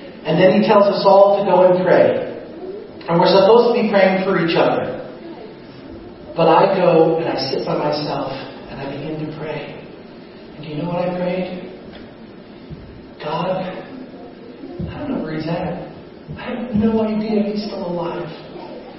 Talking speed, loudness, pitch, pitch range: 165 wpm, -17 LUFS, 185 Hz, 165-200 Hz